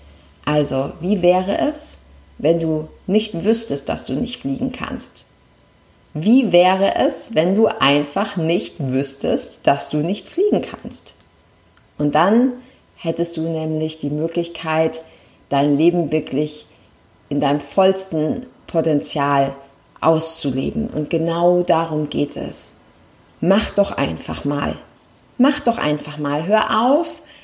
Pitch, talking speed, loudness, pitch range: 165 Hz, 120 wpm, -19 LUFS, 150-200 Hz